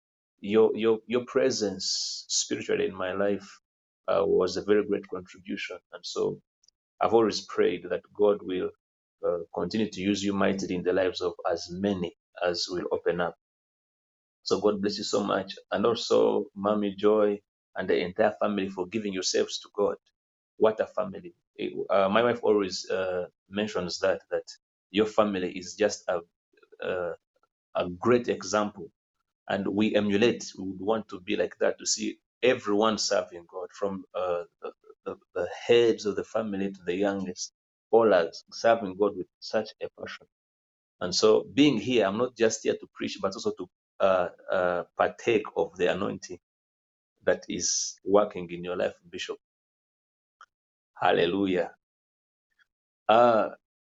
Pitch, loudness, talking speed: 105 Hz, -28 LUFS, 155 wpm